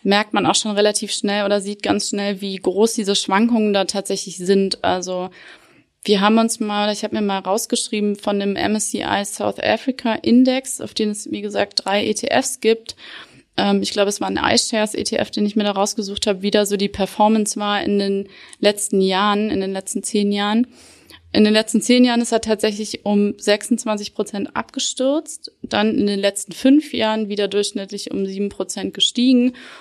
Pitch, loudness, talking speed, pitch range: 210 Hz, -19 LUFS, 185 wpm, 200-225 Hz